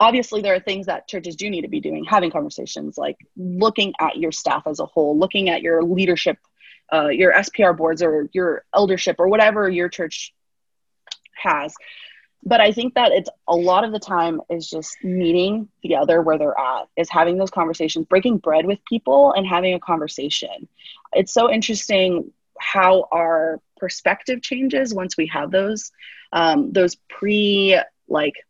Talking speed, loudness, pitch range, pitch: 170 wpm, -19 LUFS, 165-205 Hz, 185 Hz